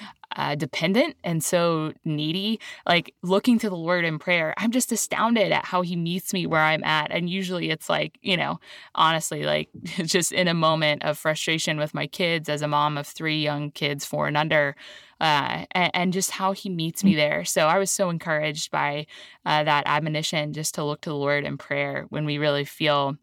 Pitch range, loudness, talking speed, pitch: 150-180 Hz, -24 LUFS, 205 wpm, 160 Hz